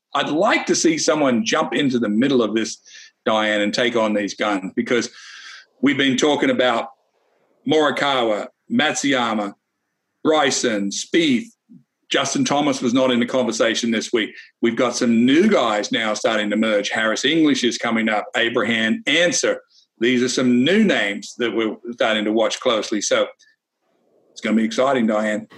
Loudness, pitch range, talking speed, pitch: -19 LUFS, 110-160 Hz, 160 wpm, 120 Hz